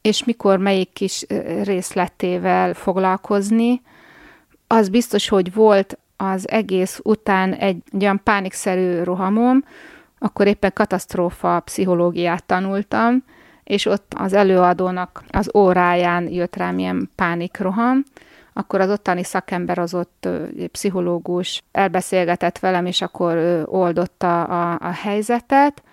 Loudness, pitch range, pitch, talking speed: -19 LUFS, 180-215 Hz, 190 Hz, 110 wpm